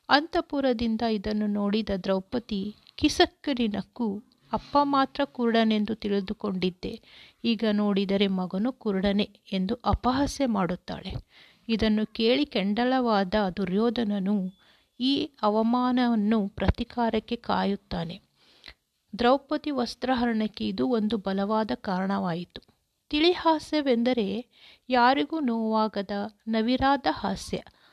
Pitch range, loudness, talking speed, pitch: 205-250 Hz, -27 LUFS, 75 wpm, 225 Hz